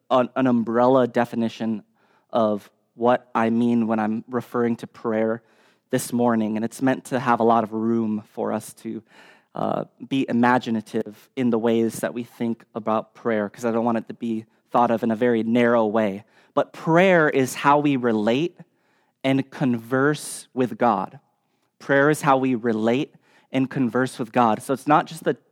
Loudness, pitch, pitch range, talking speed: -22 LUFS, 120 Hz, 115-130 Hz, 175 wpm